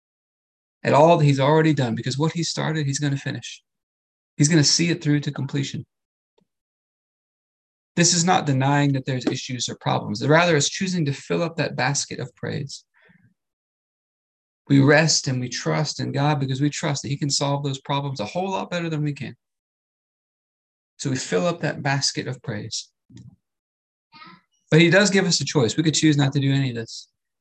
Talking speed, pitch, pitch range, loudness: 195 wpm, 145 Hz, 130-155 Hz, -21 LUFS